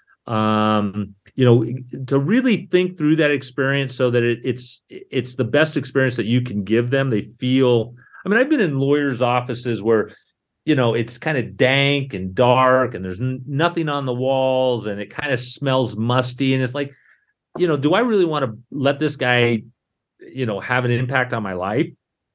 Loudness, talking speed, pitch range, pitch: -19 LUFS, 195 wpm, 120-140 Hz, 130 Hz